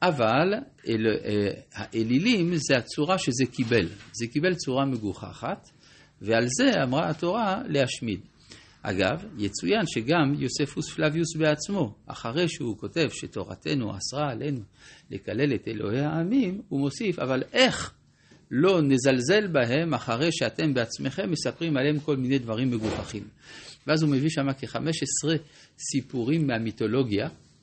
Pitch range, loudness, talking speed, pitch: 115-160 Hz, -26 LUFS, 120 wpm, 140 Hz